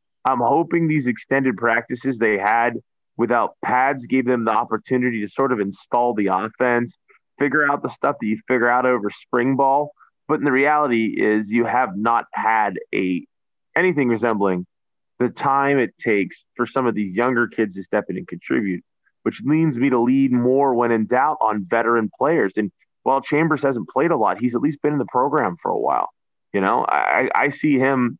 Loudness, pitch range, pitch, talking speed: -20 LUFS, 115-135 Hz, 125 Hz, 195 wpm